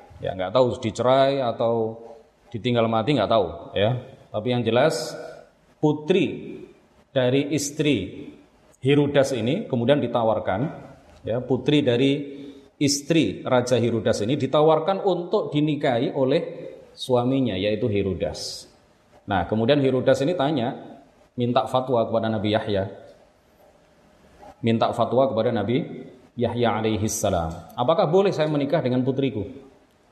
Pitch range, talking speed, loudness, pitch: 115-145 Hz, 115 wpm, -23 LUFS, 130 Hz